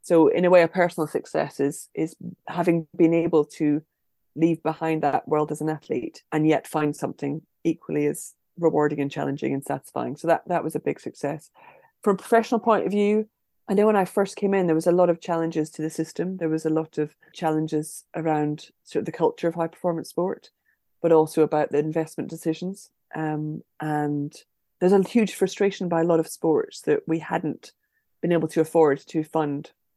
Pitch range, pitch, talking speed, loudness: 155-185 Hz, 160 Hz, 200 wpm, -24 LUFS